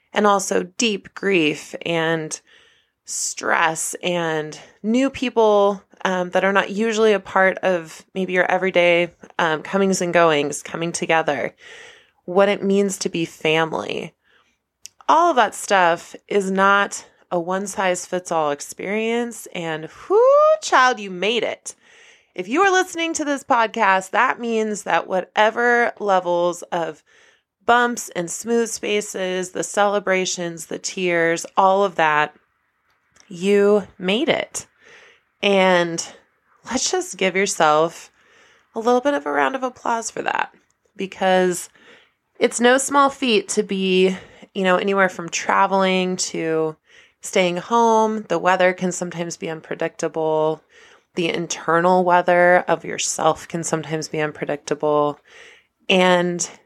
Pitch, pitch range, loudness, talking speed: 190 Hz, 175-230 Hz, -19 LUFS, 125 wpm